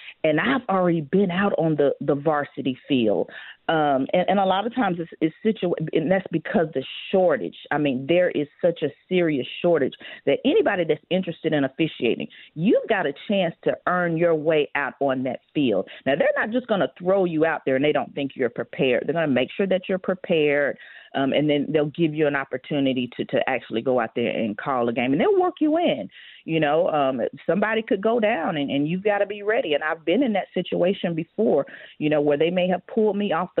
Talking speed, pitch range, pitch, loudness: 230 wpm, 145-195 Hz, 165 Hz, -23 LUFS